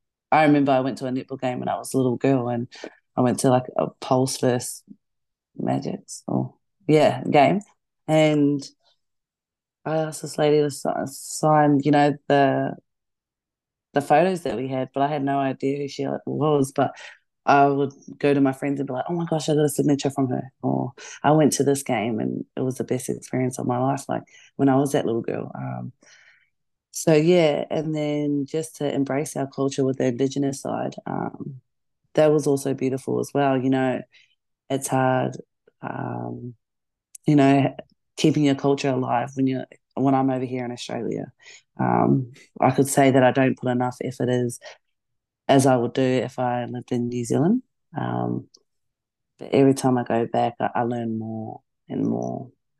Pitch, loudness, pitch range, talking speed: 135 Hz, -23 LUFS, 125-145 Hz, 185 wpm